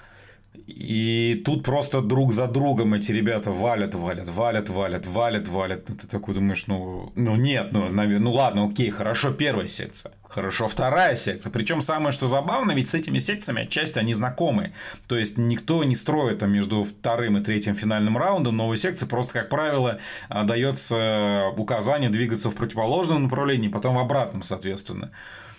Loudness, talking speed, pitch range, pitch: -24 LUFS, 160 wpm, 105-130 Hz, 115 Hz